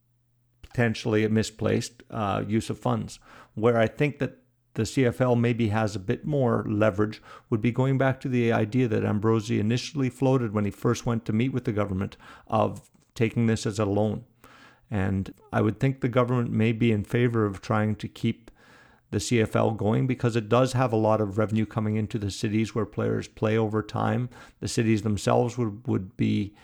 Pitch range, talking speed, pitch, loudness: 110-120 Hz, 190 wpm, 115 Hz, -26 LUFS